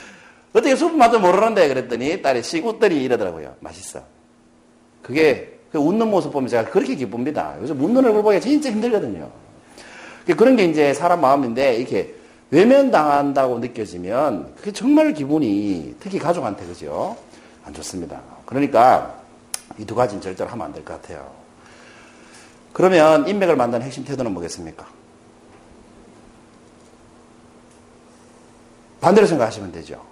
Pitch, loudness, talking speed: 155 Hz, -18 LUFS, 310 characters per minute